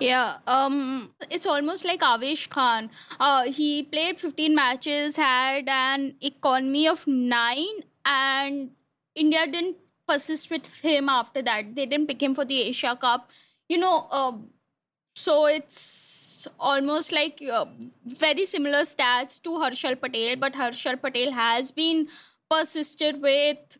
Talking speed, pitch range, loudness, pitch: 135 wpm, 255-310 Hz, -24 LUFS, 280 Hz